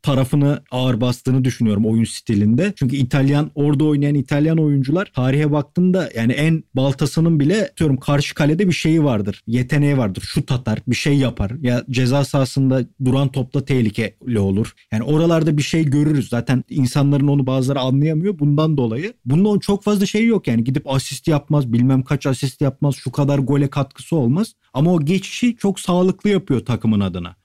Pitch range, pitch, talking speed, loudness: 125-155 Hz, 140 Hz, 165 wpm, -18 LUFS